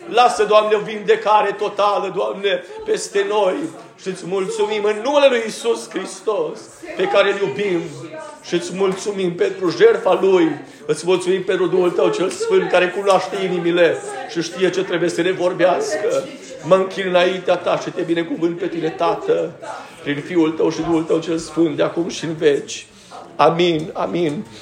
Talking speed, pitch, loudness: 165 wpm, 200 Hz, -18 LUFS